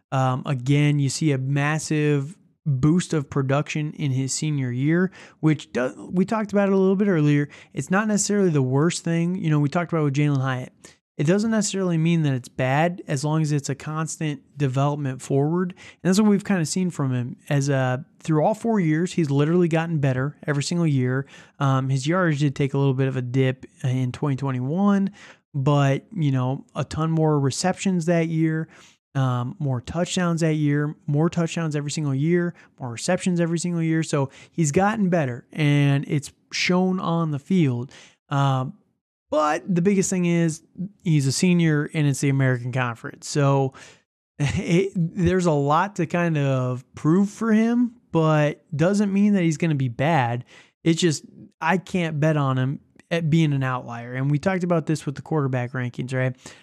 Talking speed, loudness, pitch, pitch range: 185 wpm, -23 LUFS, 155 Hz, 140-175 Hz